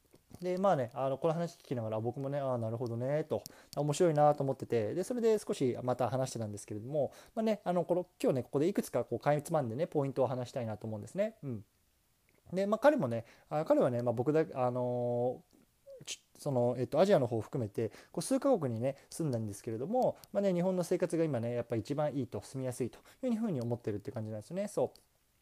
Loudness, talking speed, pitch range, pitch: -34 LUFS, 445 characters per minute, 120-175 Hz, 135 Hz